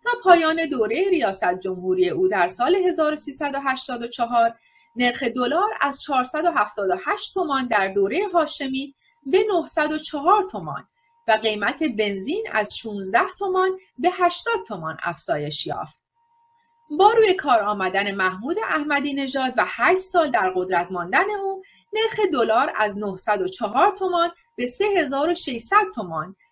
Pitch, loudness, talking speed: 290 Hz, -22 LUFS, 120 wpm